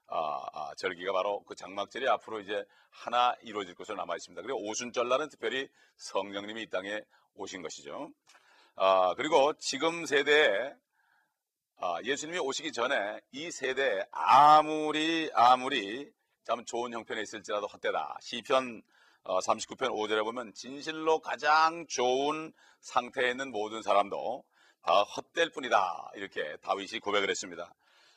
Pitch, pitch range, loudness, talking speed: 130 Hz, 110-155 Hz, -30 LUFS, 300 characters per minute